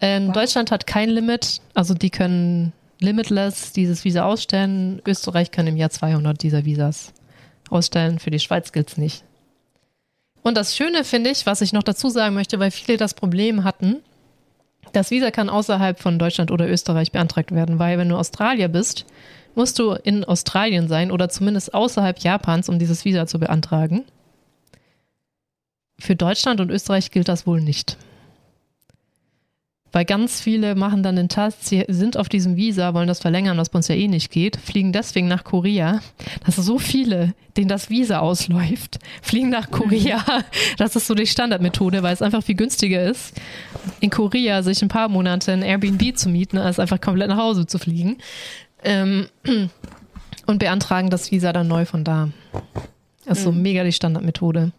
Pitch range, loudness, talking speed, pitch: 175-210 Hz, -20 LUFS, 175 wpm, 190 Hz